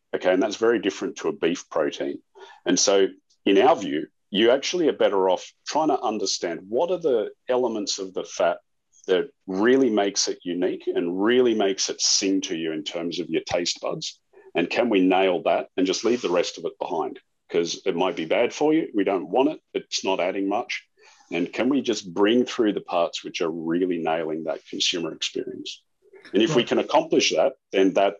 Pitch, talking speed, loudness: 365 Hz, 210 wpm, -23 LUFS